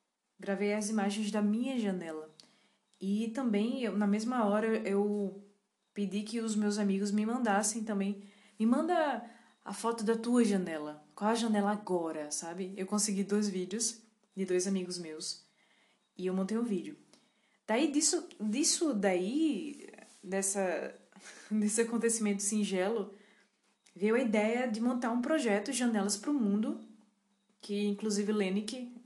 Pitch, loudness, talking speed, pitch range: 210 Hz, -33 LUFS, 140 wpm, 200-230 Hz